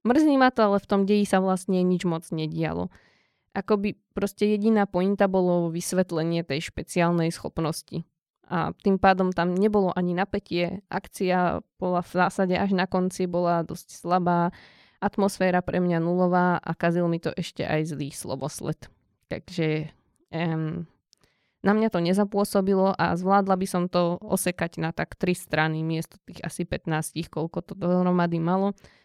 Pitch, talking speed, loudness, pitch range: 180 Hz, 155 wpm, -25 LUFS, 165-195 Hz